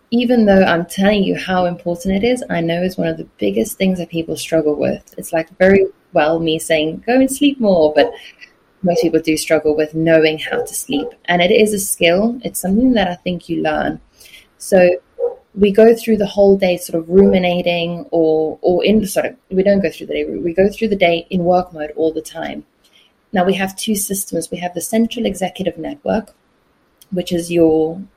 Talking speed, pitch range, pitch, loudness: 215 wpm, 165-200 Hz, 180 Hz, -16 LUFS